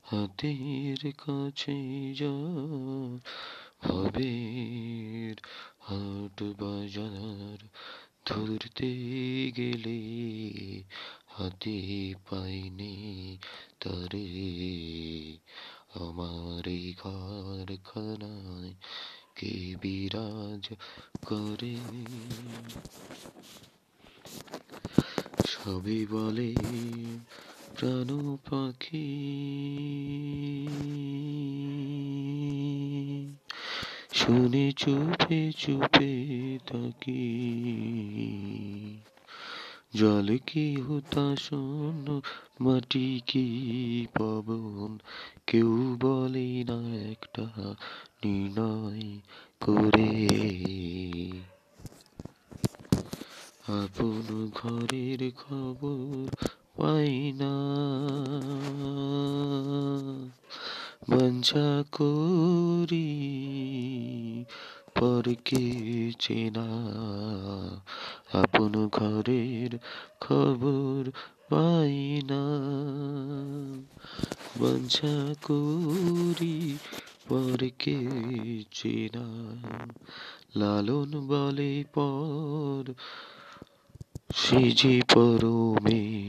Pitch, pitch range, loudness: 120 Hz, 105-140 Hz, -30 LUFS